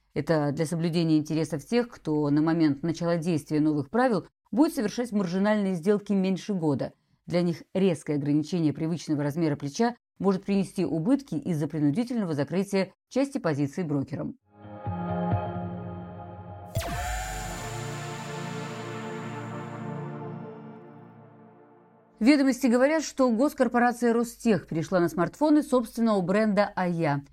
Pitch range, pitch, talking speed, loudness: 150-220 Hz, 170 Hz, 100 wpm, -27 LUFS